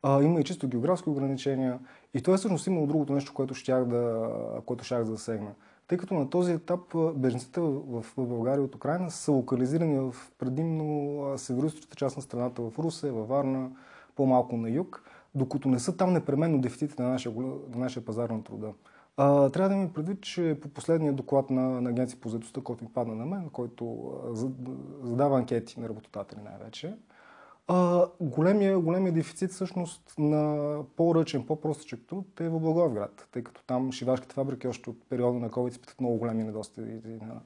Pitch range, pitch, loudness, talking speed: 125-160 Hz, 135 Hz, -30 LUFS, 170 wpm